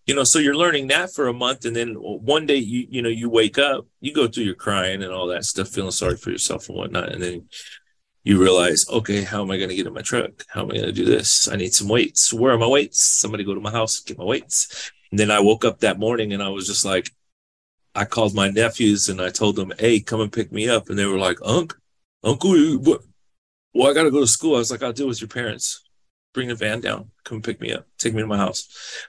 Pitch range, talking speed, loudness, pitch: 100-120 Hz, 270 wpm, -20 LUFS, 110 Hz